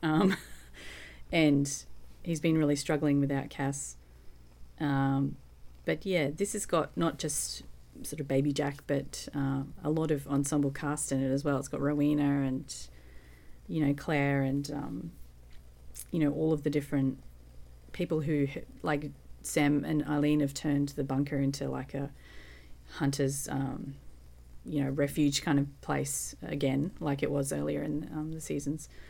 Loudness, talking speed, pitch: -31 LUFS, 155 wpm, 140 Hz